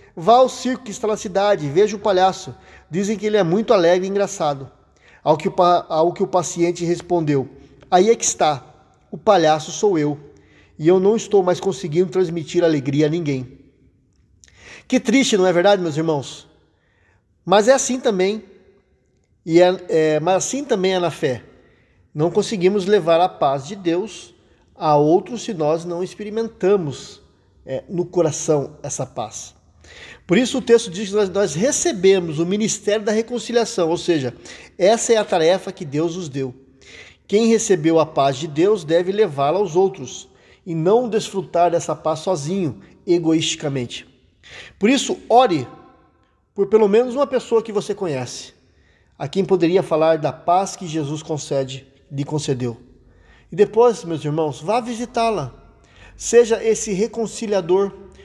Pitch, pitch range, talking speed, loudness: 175 Hz, 150-205 Hz, 155 wpm, -19 LUFS